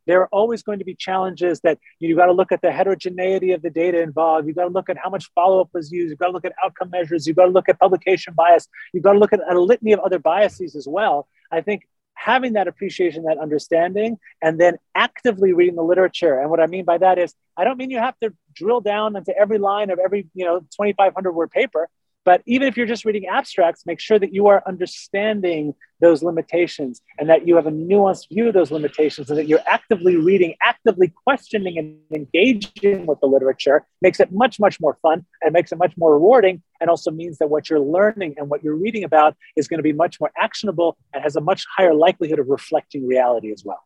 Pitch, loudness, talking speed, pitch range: 180 Hz, -18 LUFS, 235 wpm, 160-195 Hz